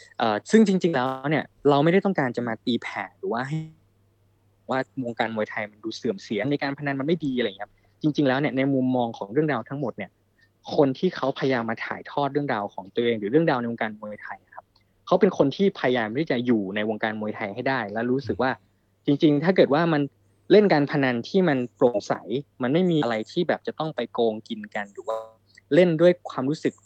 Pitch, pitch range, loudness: 130 Hz, 110-150 Hz, -24 LUFS